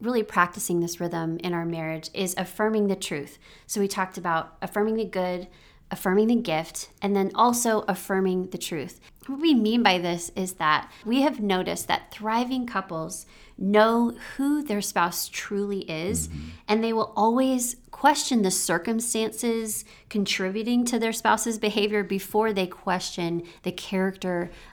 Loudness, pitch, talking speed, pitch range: -25 LUFS, 195 Hz, 155 wpm, 180-220 Hz